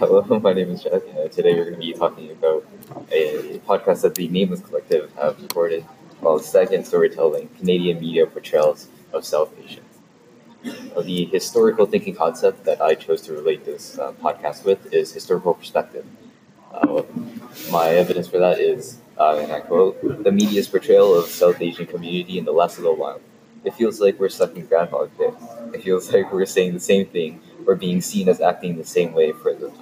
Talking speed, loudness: 195 wpm, -20 LUFS